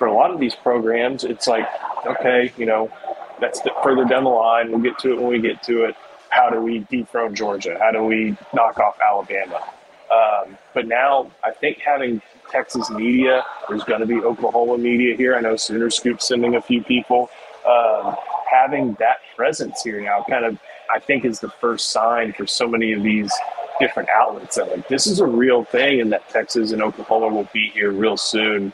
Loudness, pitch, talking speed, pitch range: -19 LUFS, 115 Hz, 205 wpm, 110-125 Hz